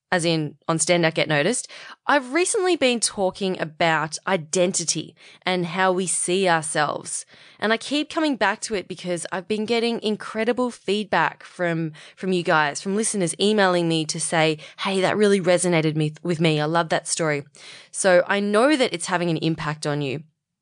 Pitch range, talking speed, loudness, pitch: 160-205 Hz, 180 wpm, -22 LUFS, 180 Hz